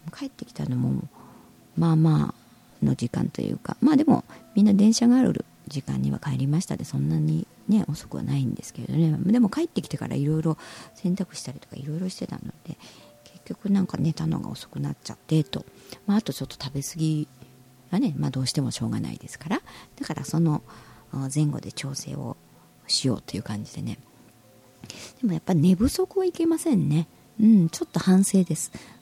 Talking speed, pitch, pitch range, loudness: 375 characters per minute, 160 Hz, 130-195 Hz, -25 LUFS